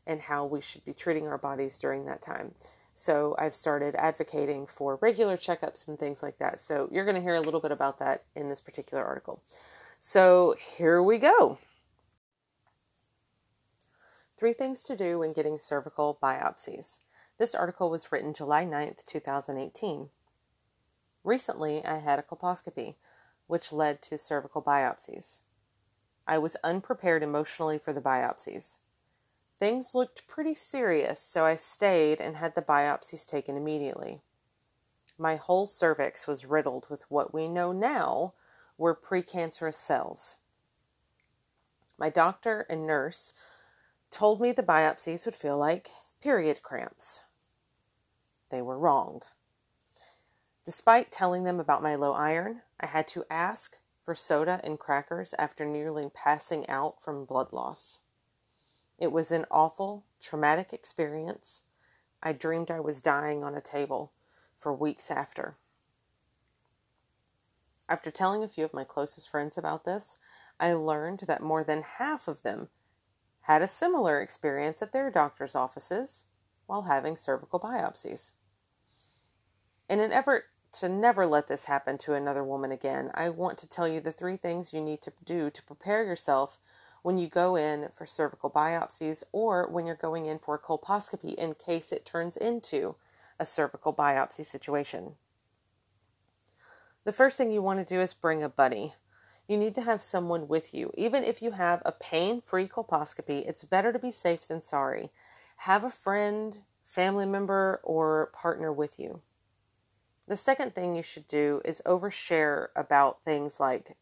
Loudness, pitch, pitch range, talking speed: -30 LUFS, 155 Hz, 145-180 Hz, 150 wpm